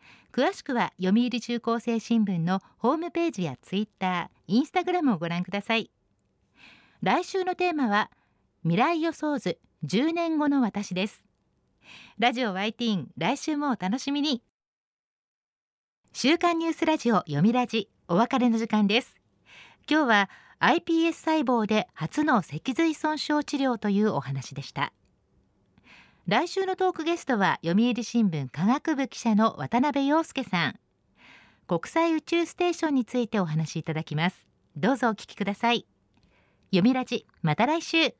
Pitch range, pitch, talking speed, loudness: 195-305 Hz, 240 Hz, 295 characters per minute, -26 LUFS